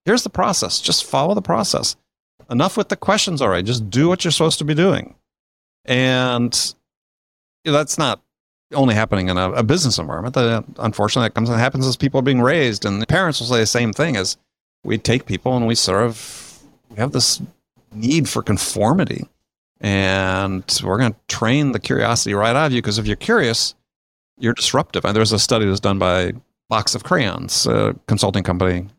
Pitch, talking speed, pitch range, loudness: 115 Hz, 195 wpm, 100-130 Hz, -18 LUFS